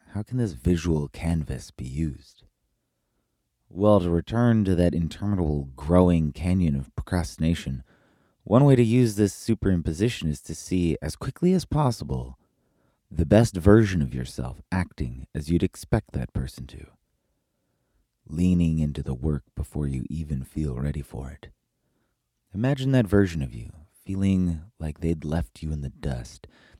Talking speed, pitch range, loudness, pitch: 150 wpm, 75-100 Hz, -25 LUFS, 85 Hz